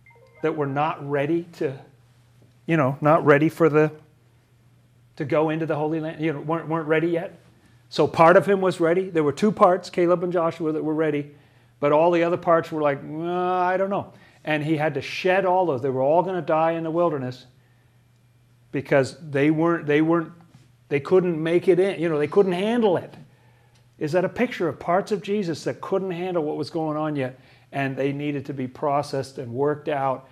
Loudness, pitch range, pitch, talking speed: -23 LUFS, 135-170 Hz, 155 Hz, 210 wpm